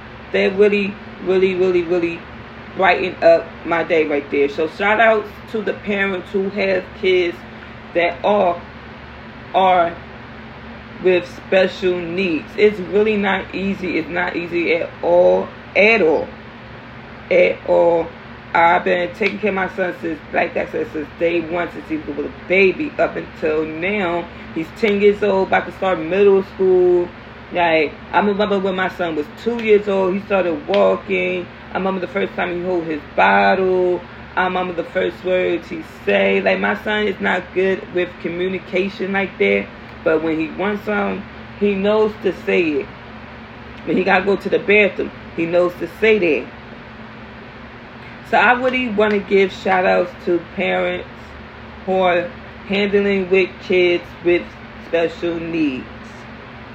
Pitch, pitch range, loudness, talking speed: 180 Hz, 155-195 Hz, -18 LUFS, 160 wpm